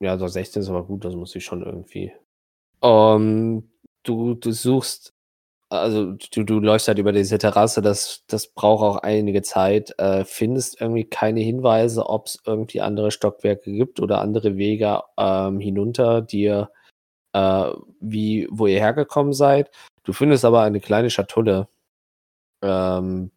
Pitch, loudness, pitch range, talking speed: 105 Hz, -20 LUFS, 95-110 Hz, 150 wpm